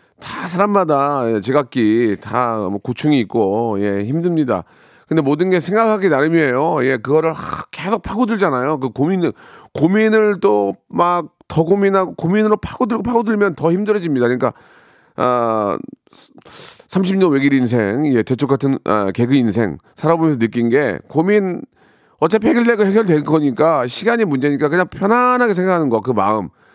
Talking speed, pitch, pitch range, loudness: 320 characters per minute, 155 Hz, 120-195 Hz, -16 LUFS